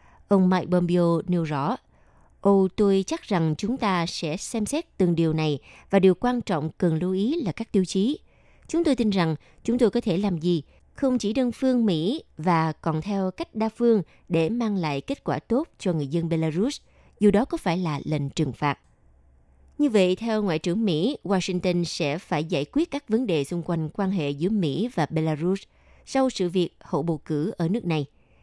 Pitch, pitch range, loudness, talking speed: 180 Hz, 160-215 Hz, -25 LUFS, 210 wpm